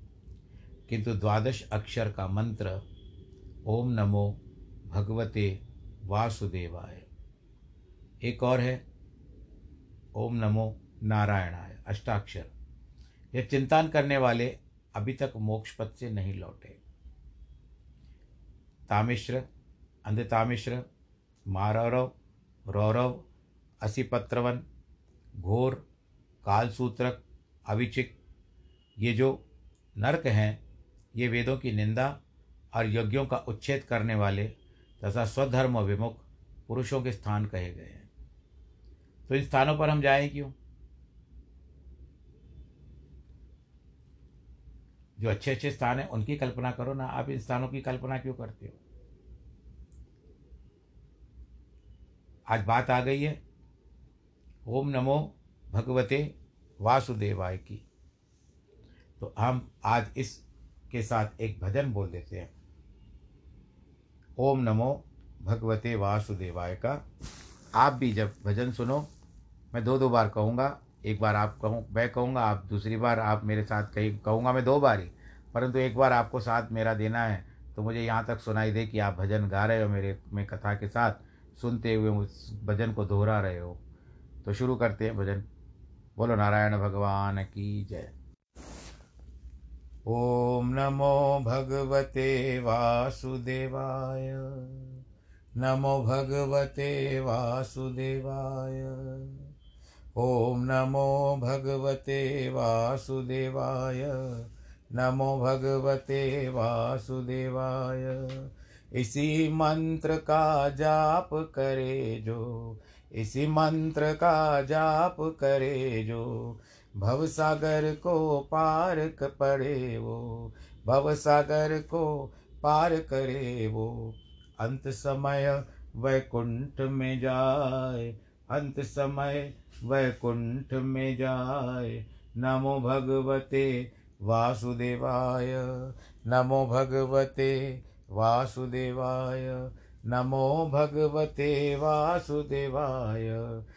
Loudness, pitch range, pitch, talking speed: -30 LUFS, 100-130 Hz, 115 Hz, 100 wpm